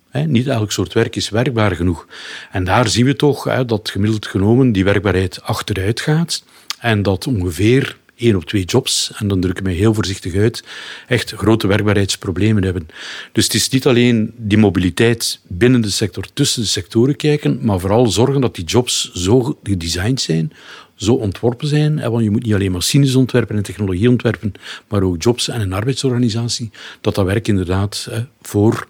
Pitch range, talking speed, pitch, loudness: 100-125 Hz, 185 wpm, 110 Hz, -16 LUFS